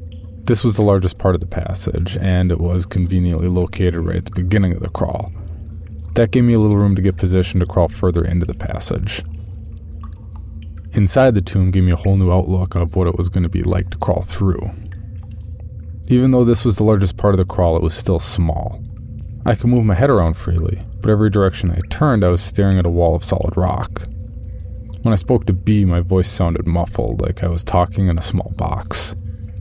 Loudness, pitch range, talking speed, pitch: -17 LUFS, 90-100 Hz, 215 wpm, 95 Hz